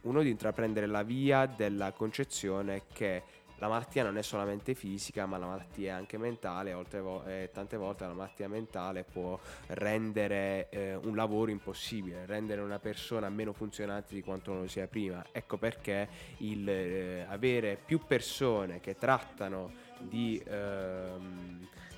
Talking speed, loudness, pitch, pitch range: 145 wpm, -36 LUFS, 100 Hz, 95-110 Hz